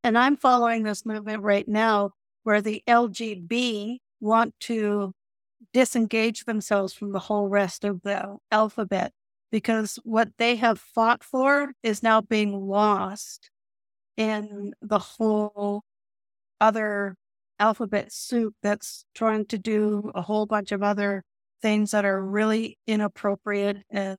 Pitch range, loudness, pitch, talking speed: 205-230 Hz, -25 LUFS, 215 Hz, 130 wpm